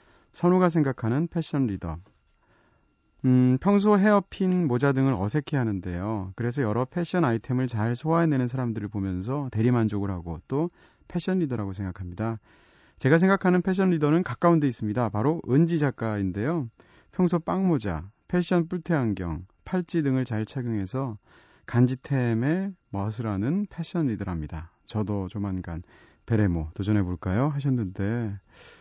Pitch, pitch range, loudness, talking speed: 125 Hz, 100-165 Hz, -26 LUFS, 315 characters per minute